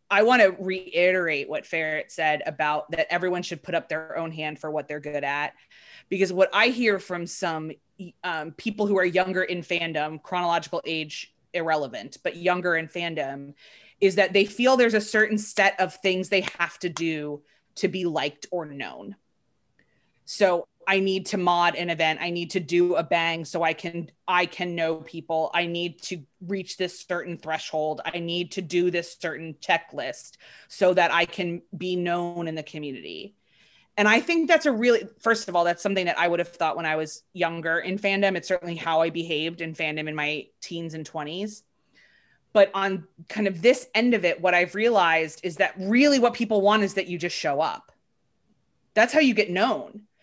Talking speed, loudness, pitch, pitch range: 195 wpm, -24 LUFS, 175 Hz, 165-195 Hz